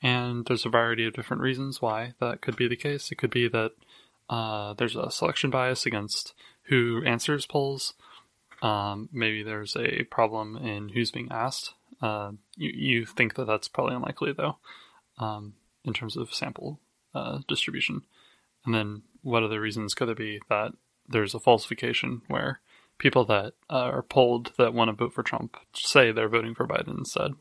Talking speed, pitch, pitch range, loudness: 175 wpm, 115 Hz, 110-125 Hz, -28 LUFS